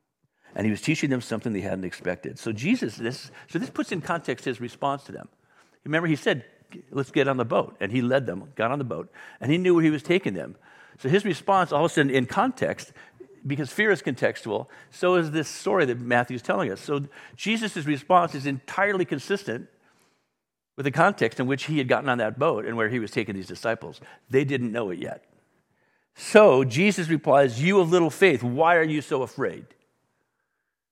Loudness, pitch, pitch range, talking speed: -24 LUFS, 145 Hz, 125-175 Hz, 210 wpm